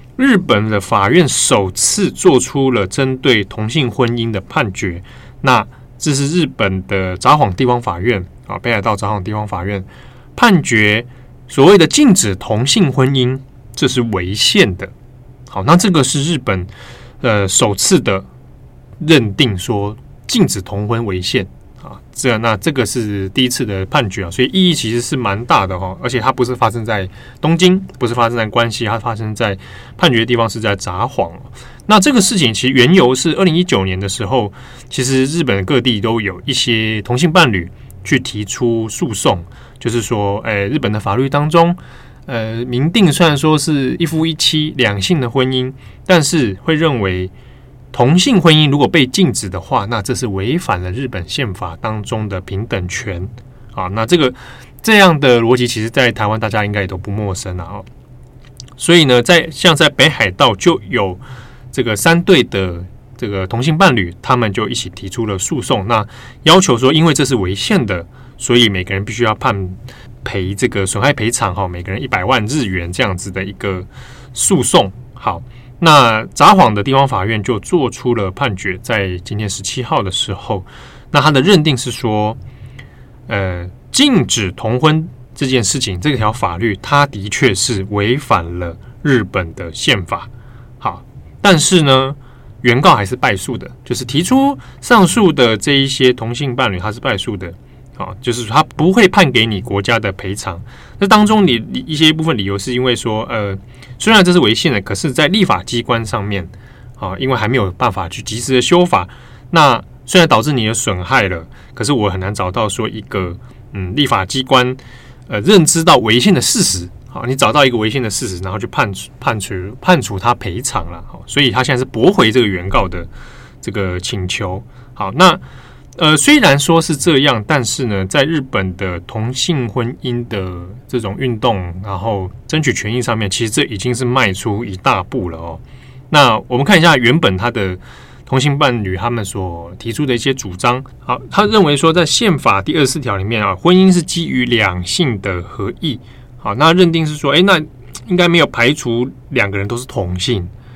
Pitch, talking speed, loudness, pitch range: 120 Hz, 270 characters per minute, -13 LUFS, 100-135 Hz